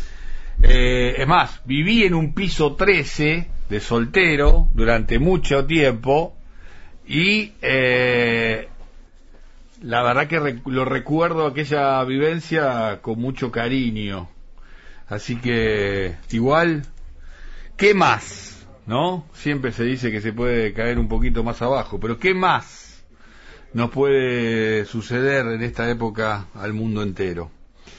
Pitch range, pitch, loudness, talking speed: 110-145 Hz, 120 Hz, -20 LUFS, 120 wpm